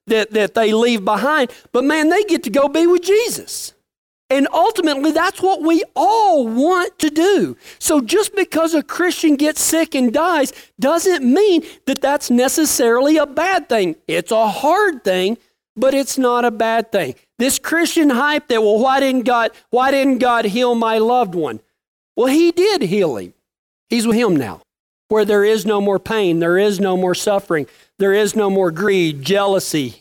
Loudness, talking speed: -16 LUFS, 180 wpm